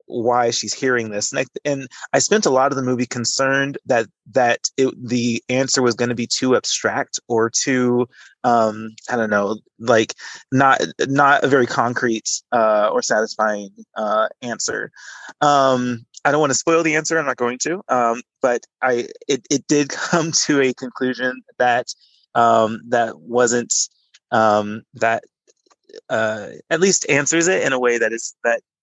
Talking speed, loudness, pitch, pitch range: 170 wpm, -19 LUFS, 125 Hz, 115-140 Hz